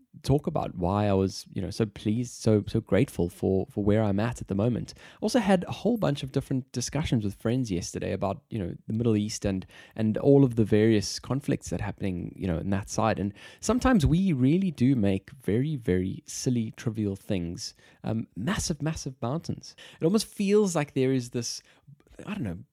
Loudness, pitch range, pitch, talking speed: -28 LUFS, 100-140 Hz, 115 Hz, 200 wpm